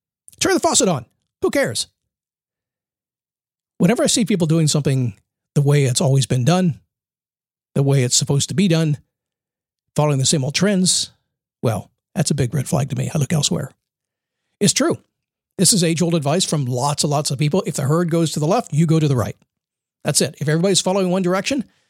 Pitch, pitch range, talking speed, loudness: 160 Hz, 145-180 Hz, 200 wpm, -18 LUFS